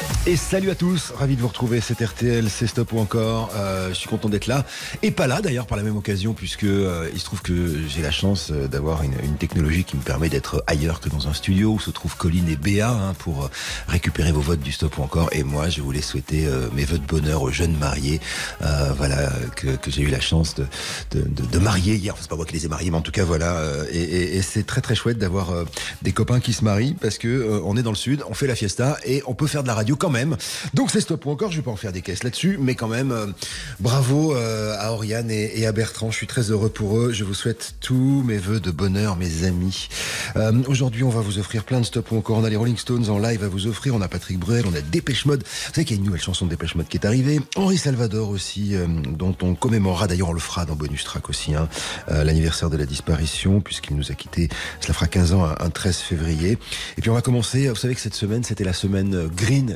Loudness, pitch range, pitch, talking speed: -22 LUFS, 80-115 Hz, 100 Hz, 275 wpm